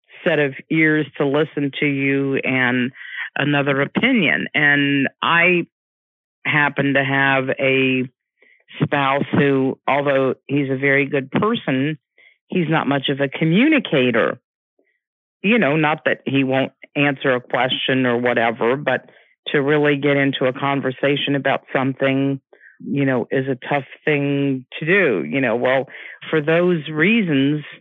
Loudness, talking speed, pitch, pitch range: -18 LUFS, 140 wpm, 140 Hz, 135-150 Hz